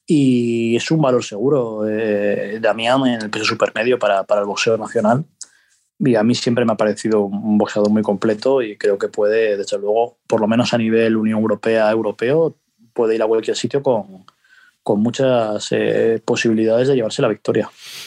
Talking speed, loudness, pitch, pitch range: 180 wpm, -17 LUFS, 115 Hz, 110-130 Hz